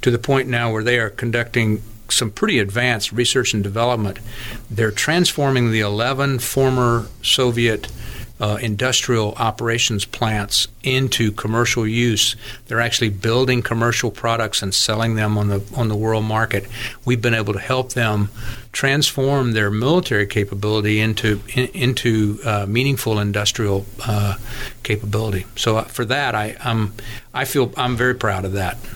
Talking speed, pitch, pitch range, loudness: 145 wpm, 115 Hz, 105-125 Hz, -19 LUFS